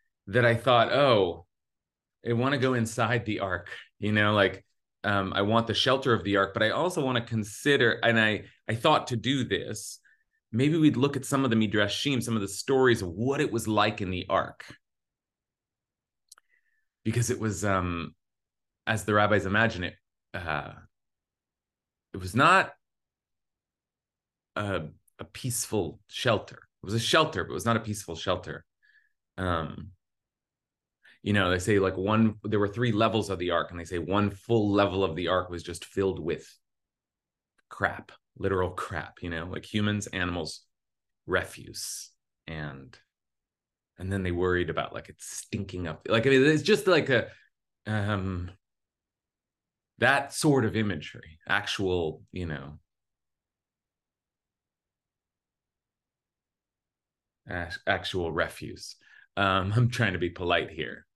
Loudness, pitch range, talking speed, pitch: -27 LUFS, 90-115 Hz, 150 wpm, 105 Hz